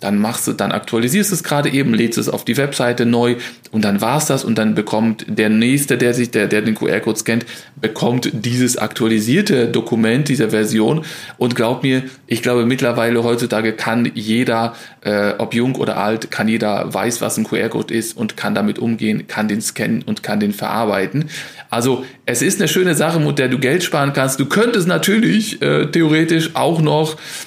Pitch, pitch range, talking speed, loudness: 120 Hz, 110-145 Hz, 190 wpm, -17 LUFS